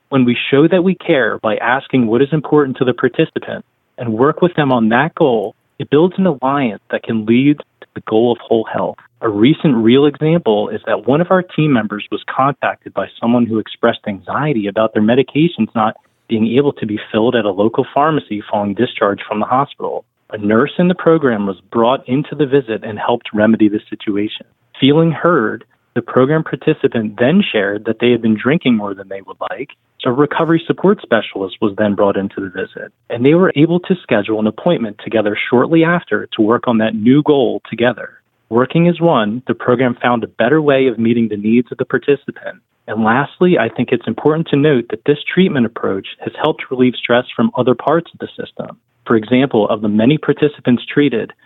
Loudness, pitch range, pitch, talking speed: -15 LUFS, 110-150 Hz, 125 Hz, 205 wpm